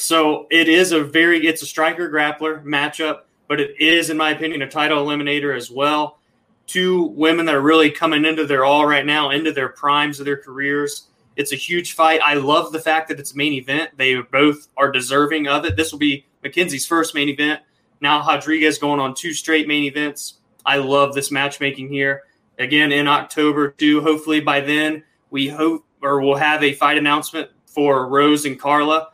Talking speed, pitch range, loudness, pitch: 200 wpm, 140-155 Hz, -17 LUFS, 150 Hz